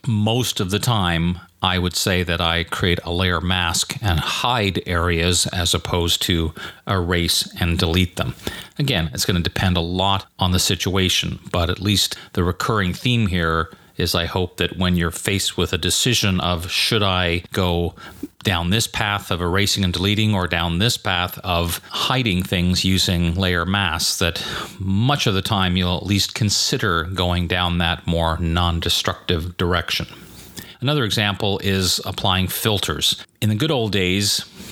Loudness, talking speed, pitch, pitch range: -20 LUFS, 165 wpm, 90 Hz, 85-100 Hz